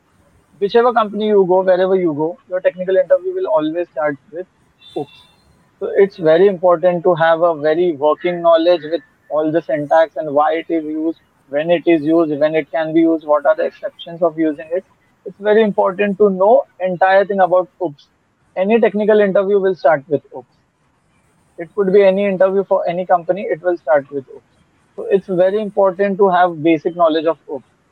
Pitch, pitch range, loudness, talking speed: 180 Hz, 165-200 Hz, -15 LUFS, 190 wpm